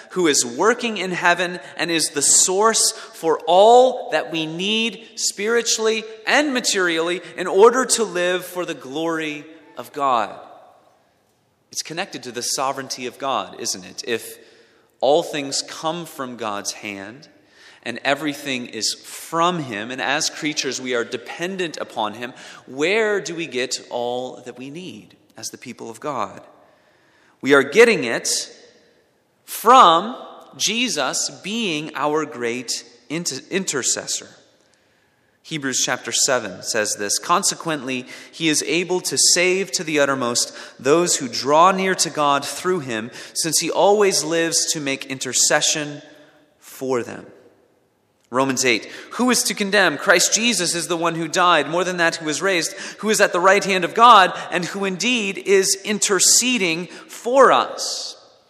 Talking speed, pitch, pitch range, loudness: 150 wpm, 165 Hz, 140-195 Hz, -19 LUFS